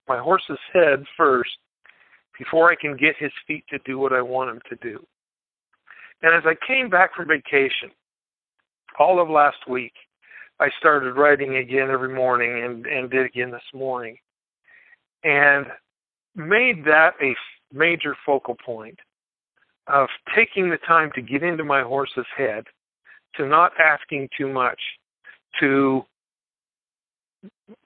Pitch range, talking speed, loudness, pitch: 130-165 Hz, 140 wpm, -20 LUFS, 140 Hz